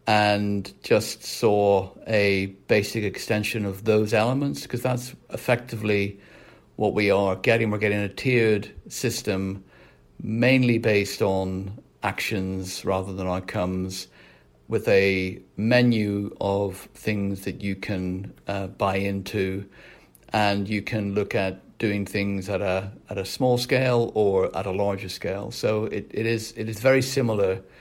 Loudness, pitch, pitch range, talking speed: -24 LUFS, 100 Hz, 95-110 Hz, 140 wpm